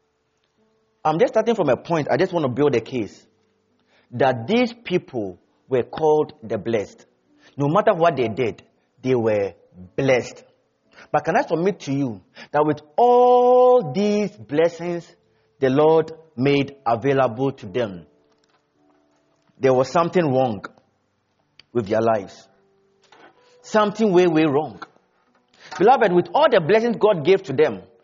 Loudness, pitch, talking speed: -20 LUFS, 150 Hz, 140 wpm